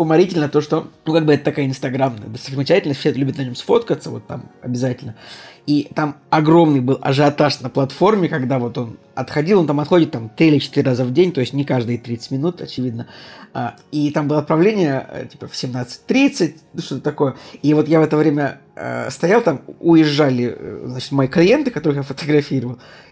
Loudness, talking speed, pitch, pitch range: -18 LUFS, 180 wpm, 145 Hz, 130-155 Hz